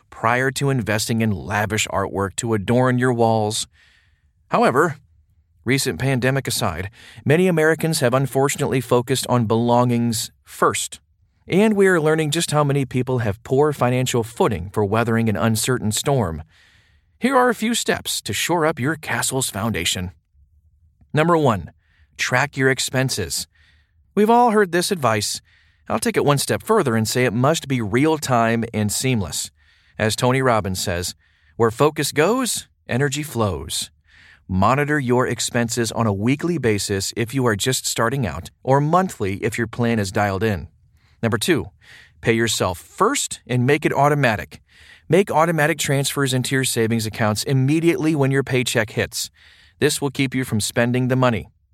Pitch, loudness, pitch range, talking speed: 120 Hz, -20 LUFS, 105-140 Hz, 155 wpm